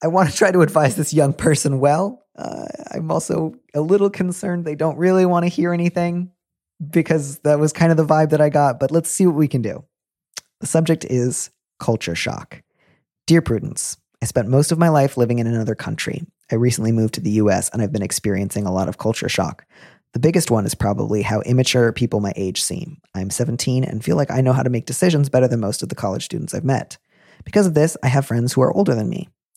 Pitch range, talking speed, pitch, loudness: 115-165 Hz, 230 wpm, 145 Hz, -19 LUFS